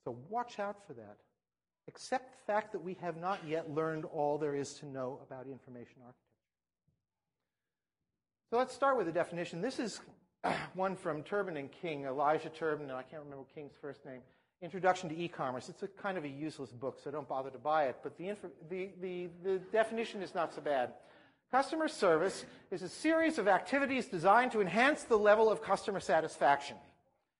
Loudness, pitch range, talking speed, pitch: -35 LUFS, 145-205 Hz, 185 wpm, 175 Hz